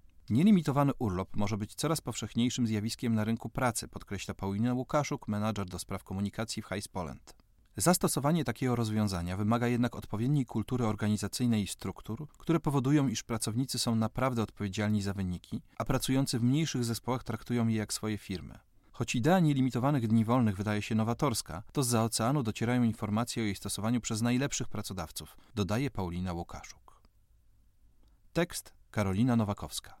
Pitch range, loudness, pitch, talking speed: 105-125 Hz, -32 LUFS, 115 Hz, 145 wpm